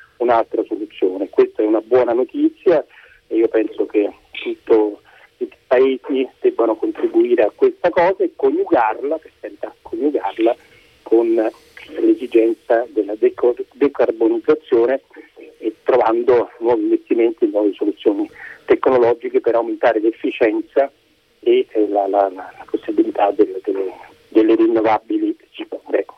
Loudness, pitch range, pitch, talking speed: -18 LUFS, 330-405 Hz, 365 Hz, 110 wpm